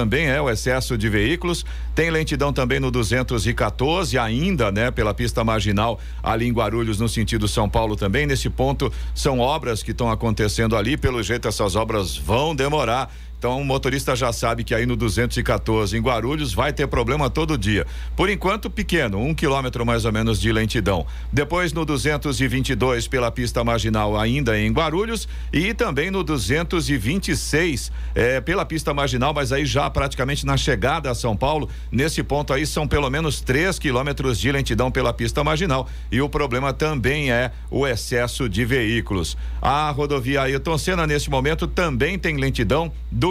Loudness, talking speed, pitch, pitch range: -21 LUFS, 170 wpm, 125 Hz, 115-145 Hz